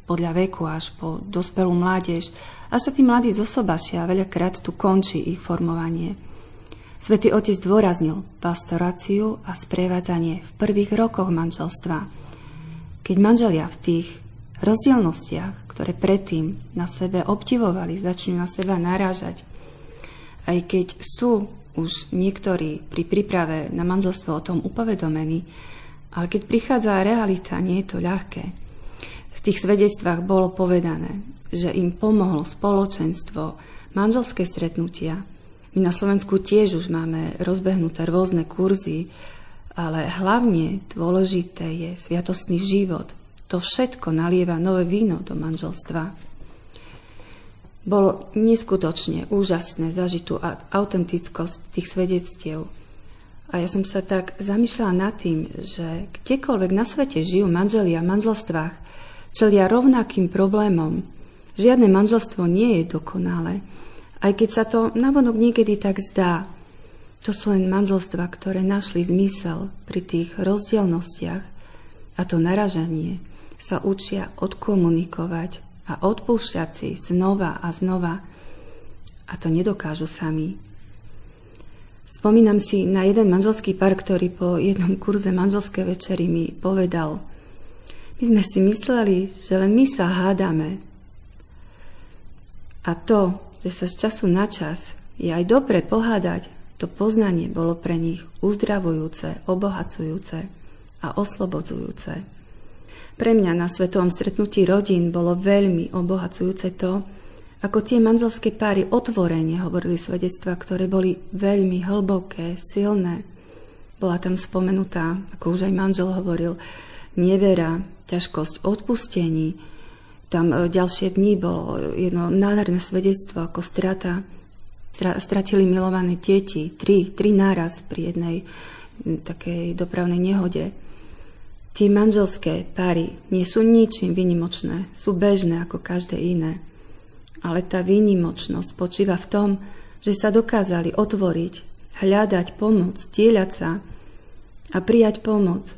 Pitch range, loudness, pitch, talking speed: 165-200 Hz, -22 LUFS, 180 Hz, 120 wpm